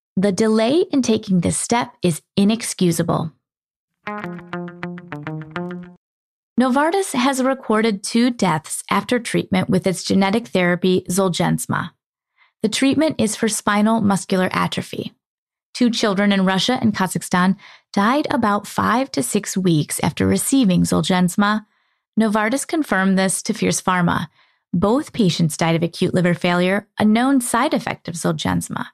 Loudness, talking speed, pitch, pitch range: -19 LUFS, 125 wpm, 200 Hz, 180-225 Hz